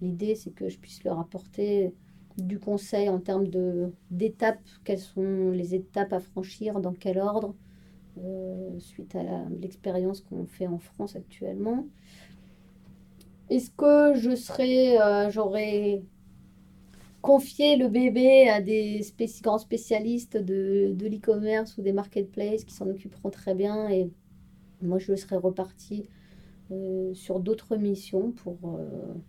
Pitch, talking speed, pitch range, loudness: 195 Hz, 135 wpm, 185-215 Hz, -27 LUFS